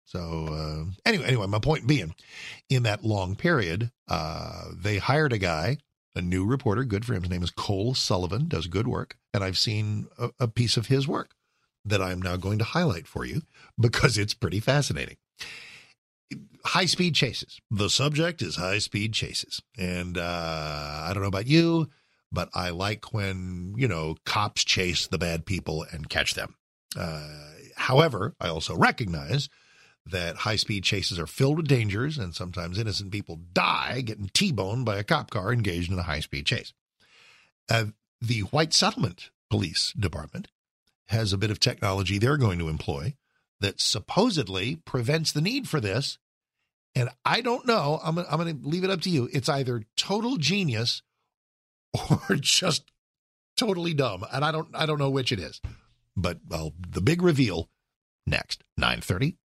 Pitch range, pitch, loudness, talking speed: 95-140 Hz, 110 Hz, -27 LUFS, 170 wpm